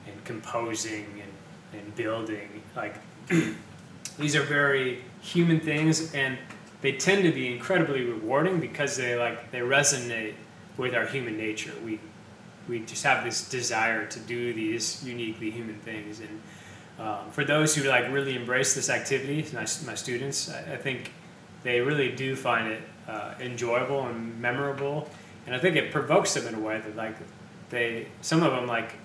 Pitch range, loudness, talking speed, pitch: 115-145 Hz, -28 LUFS, 165 wpm, 125 Hz